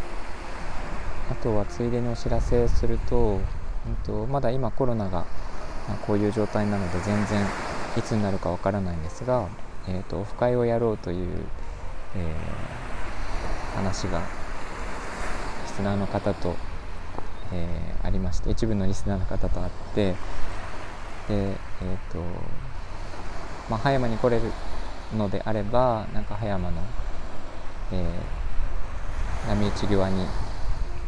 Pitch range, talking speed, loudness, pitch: 85-105 Hz, 240 characters per minute, -29 LUFS, 95 Hz